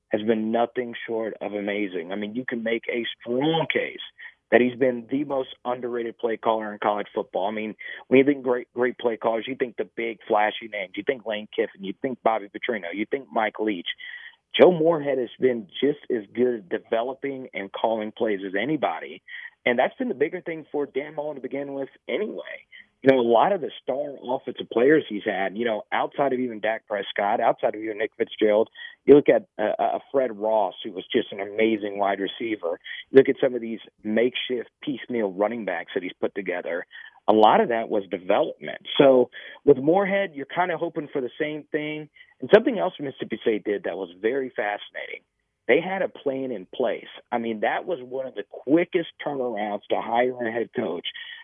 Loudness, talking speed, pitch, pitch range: -25 LUFS, 205 wpm, 125 Hz, 110-150 Hz